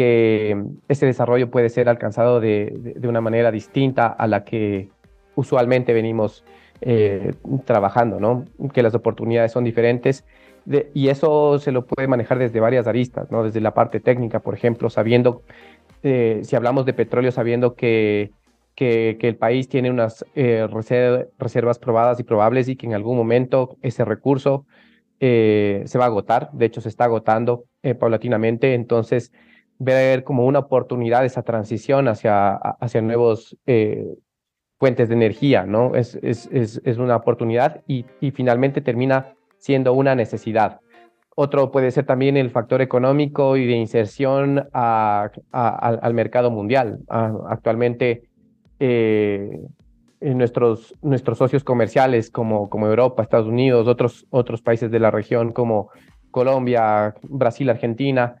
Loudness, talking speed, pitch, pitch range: -19 LUFS, 150 wpm, 120 Hz, 115-130 Hz